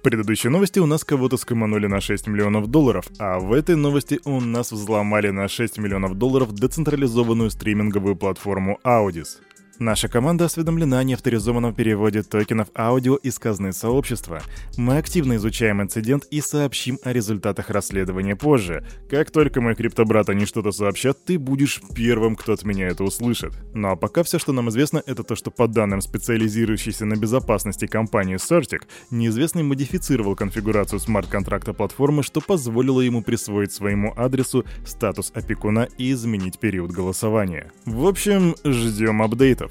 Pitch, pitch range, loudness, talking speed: 115 Hz, 105-135 Hz, -21 LUFS, 150 wpm